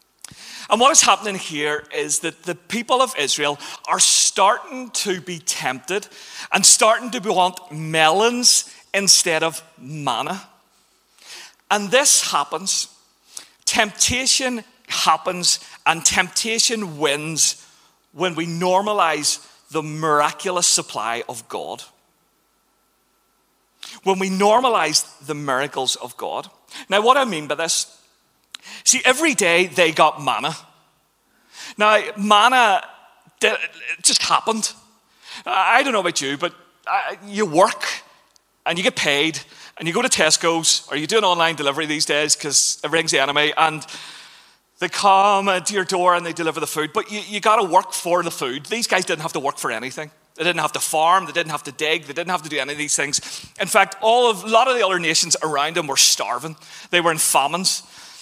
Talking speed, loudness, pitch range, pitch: 165 wpm, -18 LUFS, 155-210 Hz, 175 Hz